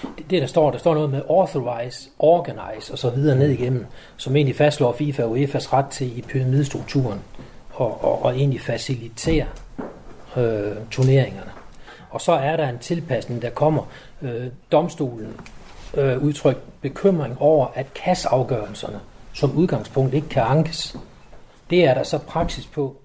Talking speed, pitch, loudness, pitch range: 155 wpm, 135 Hz, -21 LUFS, 125-150 Hz